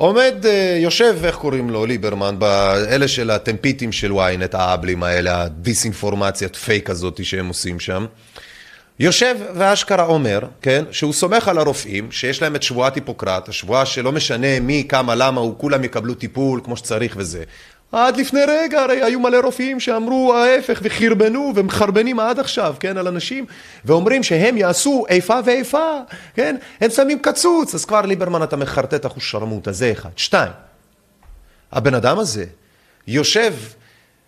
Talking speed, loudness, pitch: 145 wpm, -17 LUFS, 145 Hz